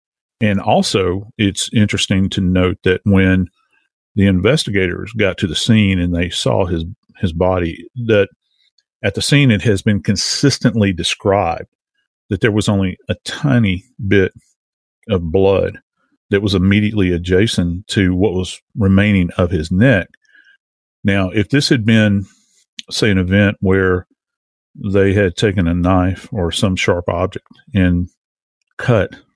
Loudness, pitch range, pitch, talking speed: -16 LUFS, 90-105 Hz, 100 Hz, 140 wpm